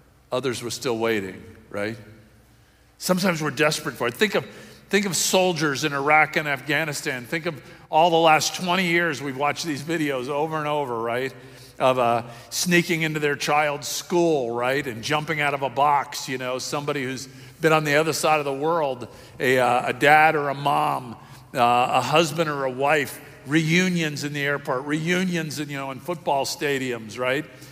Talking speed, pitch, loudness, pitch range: 185 wpm, 145 Hz, -22 LUFS, 130-155 Hz